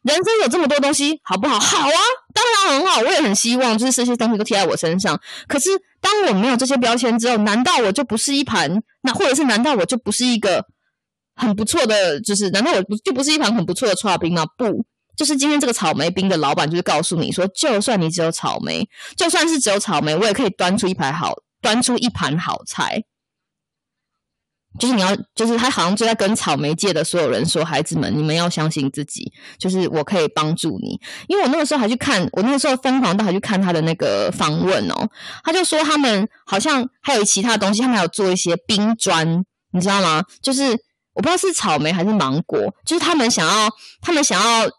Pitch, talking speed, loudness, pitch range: 220 Hz, 335 characters per minute, -18 LUFS, 180-265 Hz